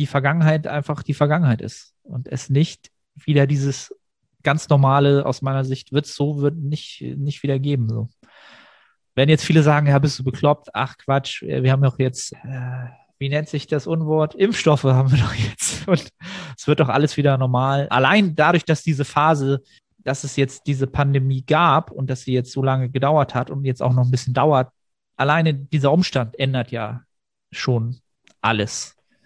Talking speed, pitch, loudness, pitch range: 185 wpm, 140 Hz, -20 LUFS, 130-150 Hz